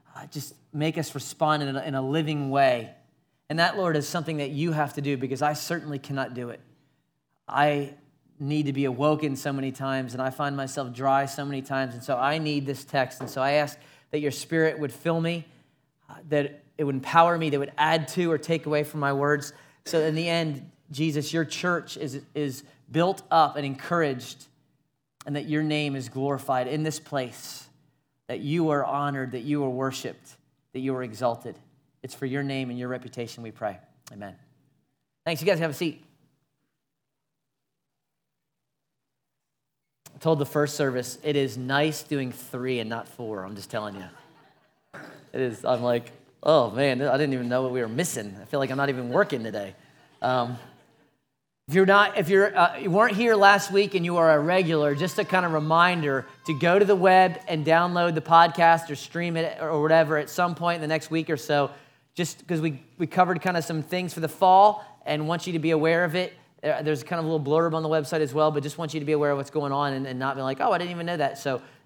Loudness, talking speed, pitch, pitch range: -25 LUFS, 220 wpm, 150 Hz, 135-165 Hz